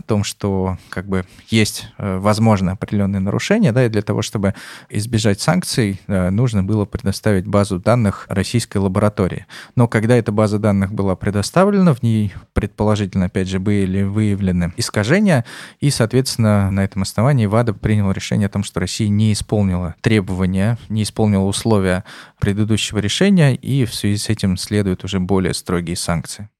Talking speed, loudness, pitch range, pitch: 155 wpm, -18 LUFS, 95-110 Hz, 105 Hz